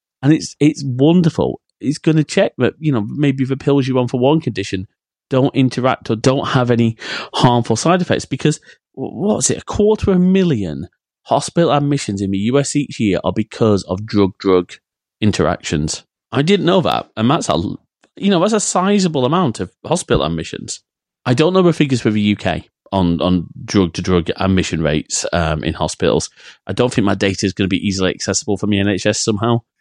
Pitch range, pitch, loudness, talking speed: 95-145 Hz, 120 Hz, -16 LUFS, 195 wpm